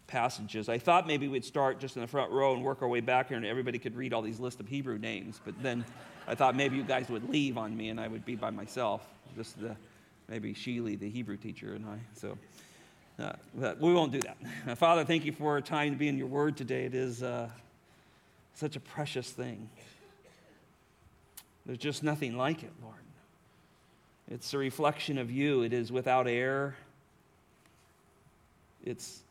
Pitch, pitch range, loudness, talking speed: 130 Hz, 115-140 Hz, -33 LUFS, 195 wpm